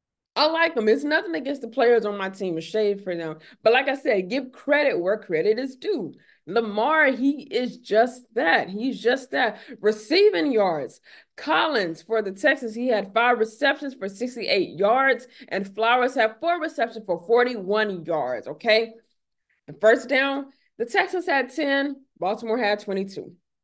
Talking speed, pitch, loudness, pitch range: 165 wpm, 235 Hz, -23 LUFS, 215-275 Hz